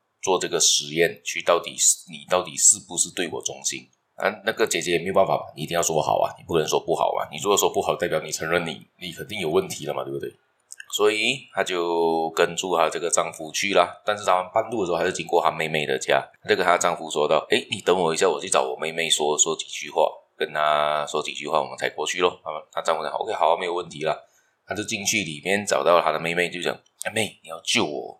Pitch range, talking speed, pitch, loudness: 75-95 Hz, 355 characters per minute, 85 Hz, -23 LUFS